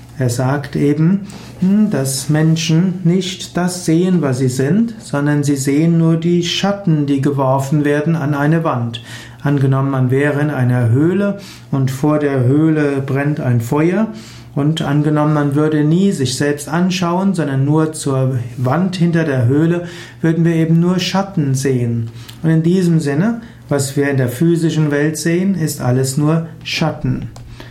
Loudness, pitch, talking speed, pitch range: -15 LUFS, 150 Hz, 155 wpm, 135-165 Hz